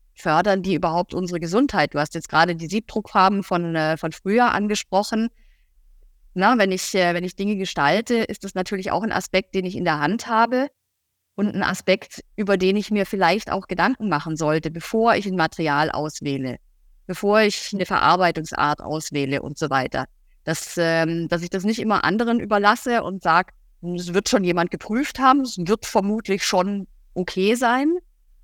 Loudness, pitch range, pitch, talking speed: -21 LUFS, 165-215 Hz, 190 Hz, 175 wpm